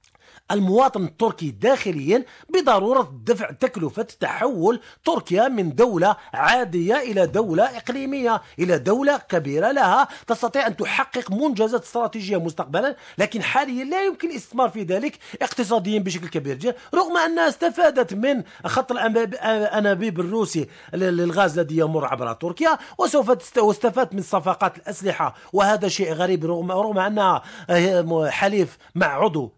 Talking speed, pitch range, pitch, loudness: 125 wpm, 185-255 Hz, 215 Hz, -21 LUFS